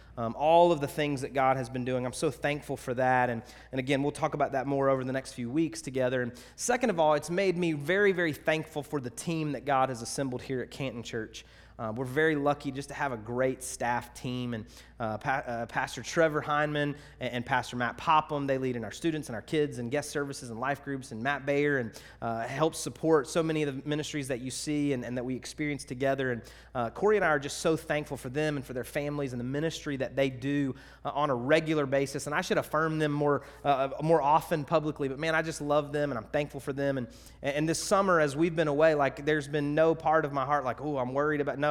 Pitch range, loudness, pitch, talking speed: 130-155 Hz, -30 LUFS, 140 Hz, 255 wpm